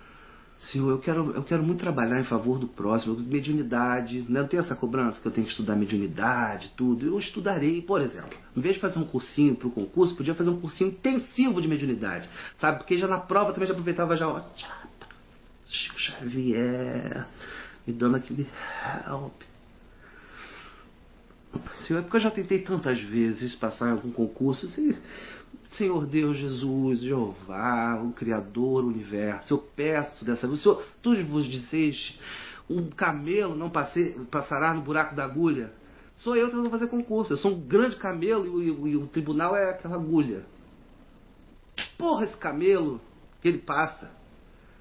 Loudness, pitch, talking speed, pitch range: -27 LUFS, 150 Hz, 165 wpm, 125-180 Hz